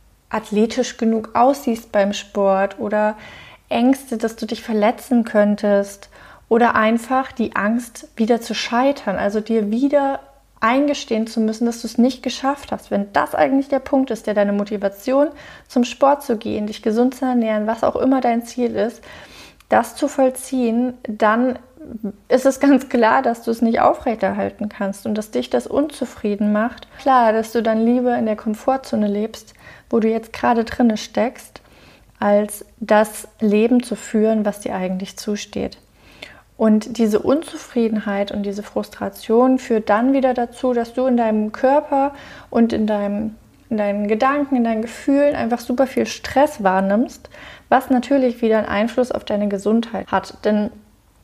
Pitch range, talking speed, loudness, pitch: 210-255 Hz, 160 wpm, -19 LUFS, 230 Hz